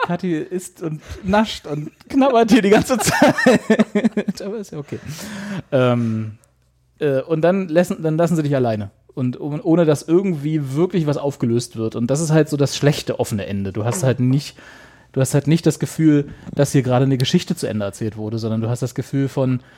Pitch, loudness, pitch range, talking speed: 145 Hz, -19 LUFS, 125-175 Hz, 205 wpm